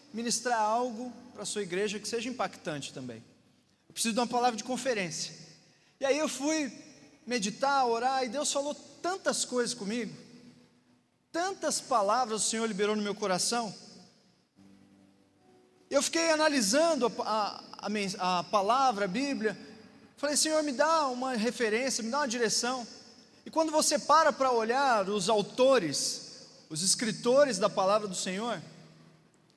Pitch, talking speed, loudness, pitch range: 235 Hz, 140 wpm, -29 LUFS, 205-275 Hz